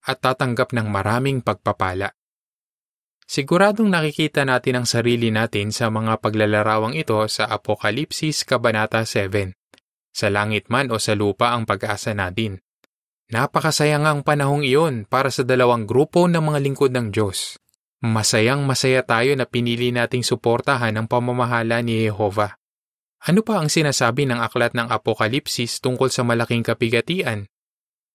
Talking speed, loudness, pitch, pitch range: 135 wpm, -20 LUFS, 120 Hz, 110-135 Hz